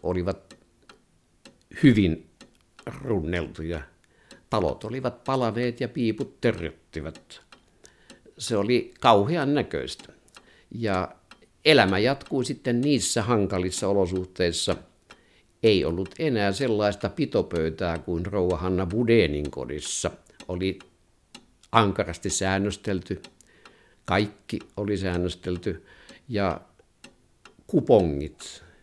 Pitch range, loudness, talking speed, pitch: 90-115 Hz, -25 LUFS, 75 wpm, 100 Hz